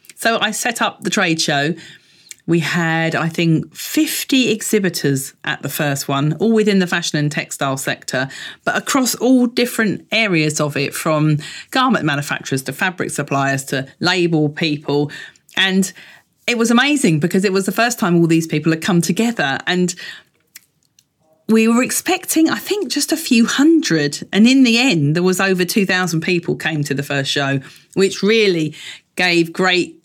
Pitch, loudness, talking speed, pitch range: 180 Hz, -16 LUFS, 170 wpm, 155-225 Hz